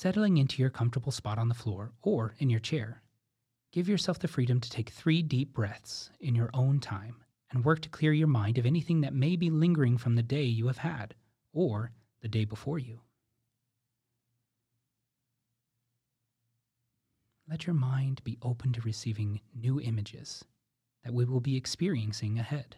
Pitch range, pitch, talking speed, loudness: 115-135 Hz, 120 Hz, 165 wpm, -31 LUFS